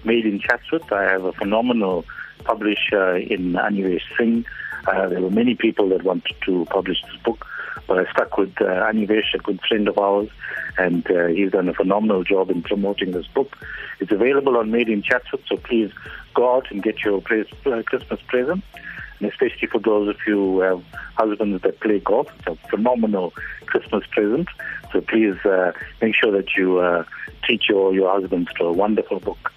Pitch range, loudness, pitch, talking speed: 95-115 Hz, -20 LUFS, 105 Hz, 185 wpm